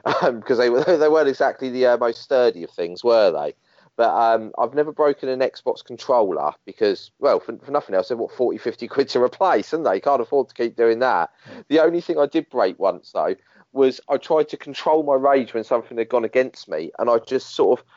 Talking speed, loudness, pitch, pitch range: 230 wpm, -20 LUFS, 130 Hz, 120-155 Hz